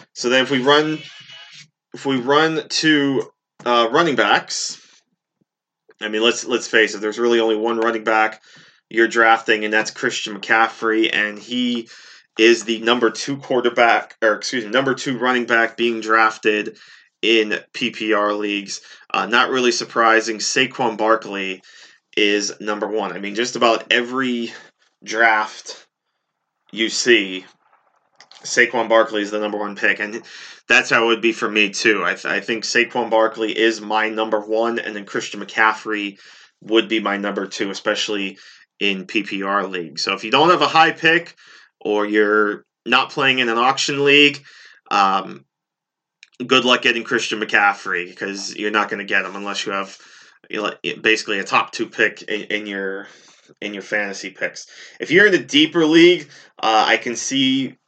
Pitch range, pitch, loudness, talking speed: 105-125 Hz, 115 Hz, -18 LUFS, 165 wpm